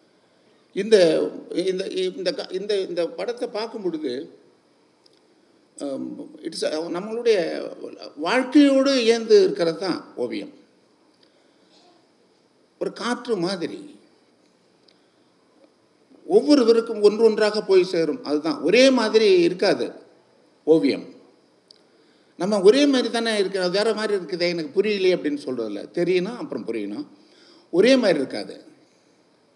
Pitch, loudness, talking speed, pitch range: 230 Hz, -21 LUFS, 85 wpm, 190-295 Hz